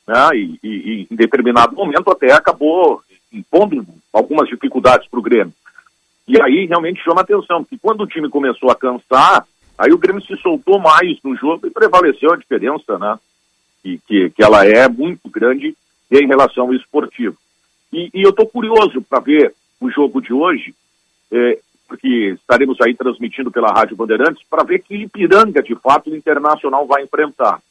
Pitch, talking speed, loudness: 170 Hz, 175 wpm, -13 LUFS